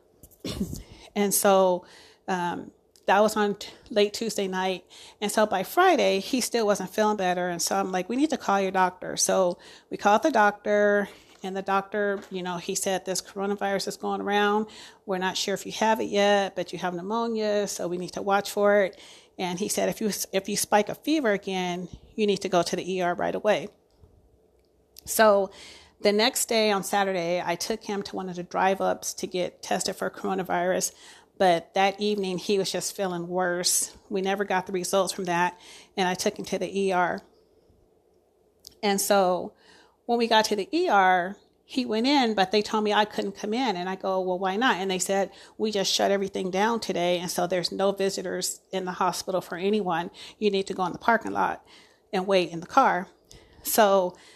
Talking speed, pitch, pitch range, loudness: 205 wpm, 195 Hz, 185-210 Hz, -26 LUFS